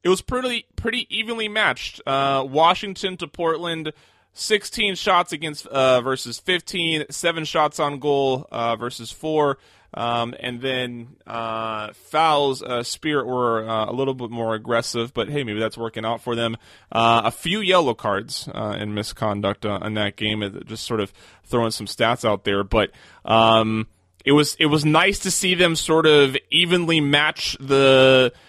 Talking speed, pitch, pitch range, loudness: 170 wpm, 130 Hz, 115-160 Hz, -21 LUFS